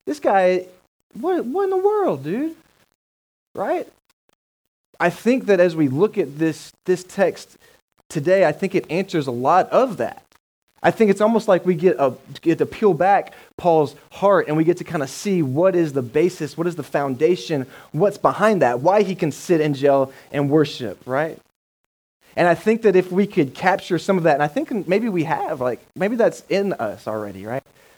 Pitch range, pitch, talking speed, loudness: 150-200 Hz, 175 Hz, 200 wpm, -20 LUFS